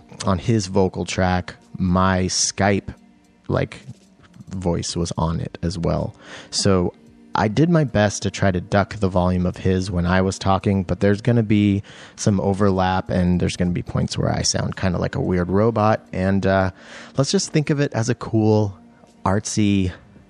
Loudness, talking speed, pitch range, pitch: -21 LUFS, 185 wpm, 90-105 Hz, 95 Hz